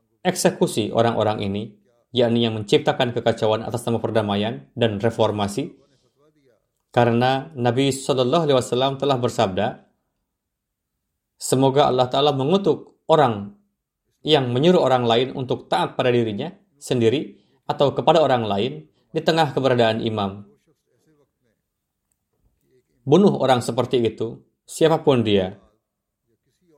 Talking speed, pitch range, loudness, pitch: 105 wpm, 110-140 Hz, -20 LUFS, 125 Hz